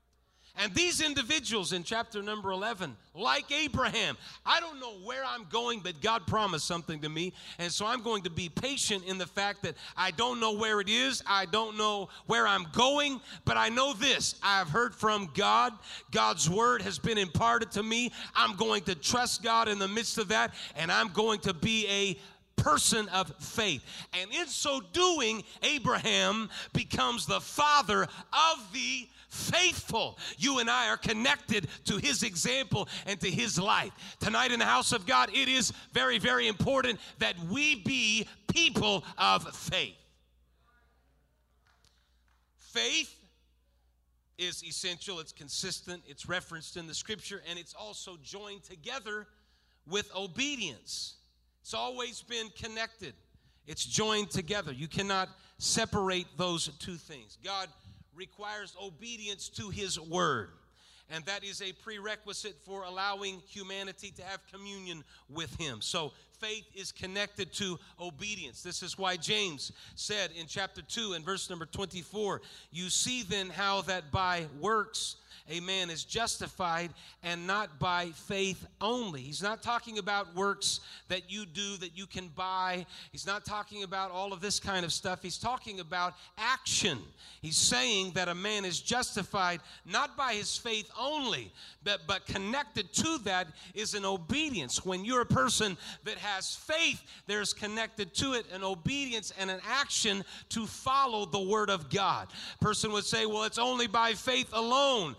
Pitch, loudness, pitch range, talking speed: 195 Hz, -31 LUFS, 180-225 Hz, 160 wpm